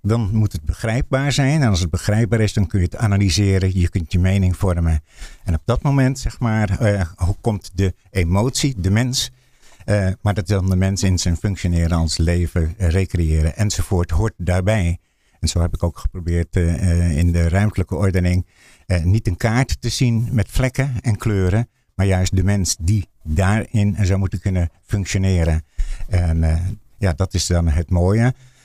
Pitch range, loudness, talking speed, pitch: 90-110 Hz, -19 LUFS, 185 wpm, 95 Hz